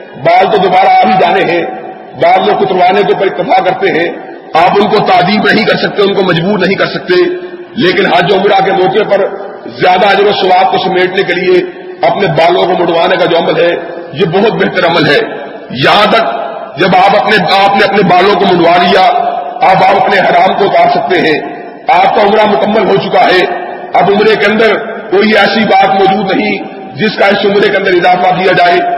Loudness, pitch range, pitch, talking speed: -8 LUFS, 185-210 Hz, 195 Hz, 205 wpm